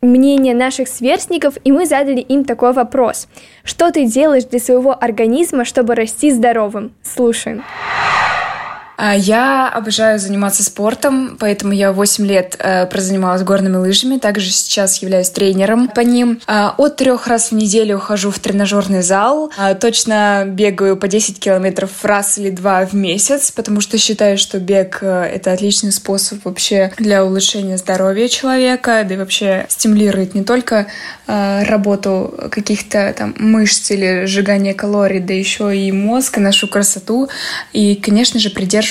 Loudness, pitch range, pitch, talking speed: -13 LUFS, 195-245 Hz, 210 Hz, 150 wpm